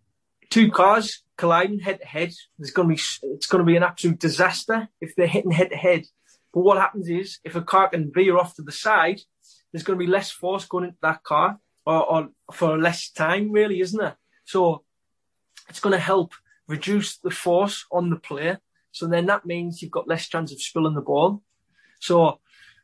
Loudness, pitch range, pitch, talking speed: -22 LUFS, 165-195 Hz, 175 Hz, 205 wpm